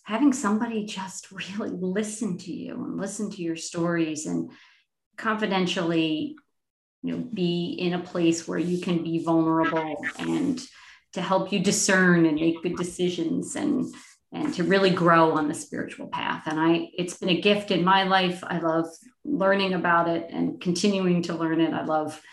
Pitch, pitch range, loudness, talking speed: 180 Hz, 165-200 Hz, -25 LUFS, 170 wpm